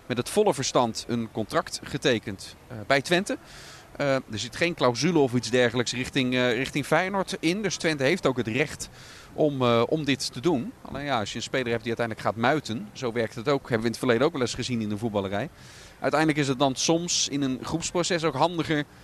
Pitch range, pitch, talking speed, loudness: 120-155 Hz, 130 Hz, 215 wpm, -26 LUFS